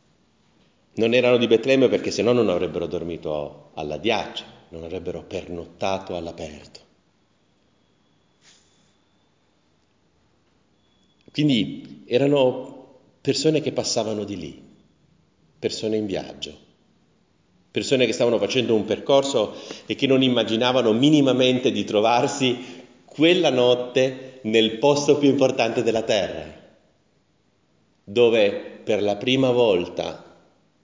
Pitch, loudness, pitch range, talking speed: 120 Hz, -21 LUFS, 105-130 Hz, 100 wpm